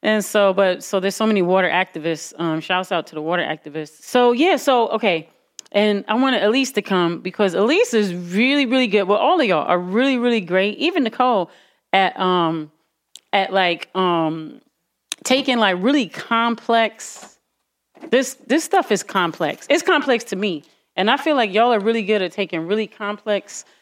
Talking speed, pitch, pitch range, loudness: 180 wpm, 205 Hz, 180-240 Hz, -19 LUFS